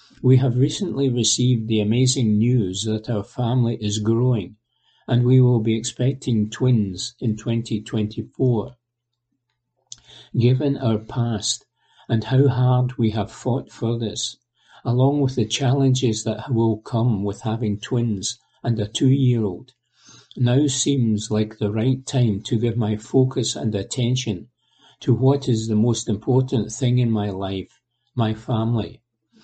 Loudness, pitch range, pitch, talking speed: -21 LUFS, 110-130 Hz, 120 Hz, 140 wpm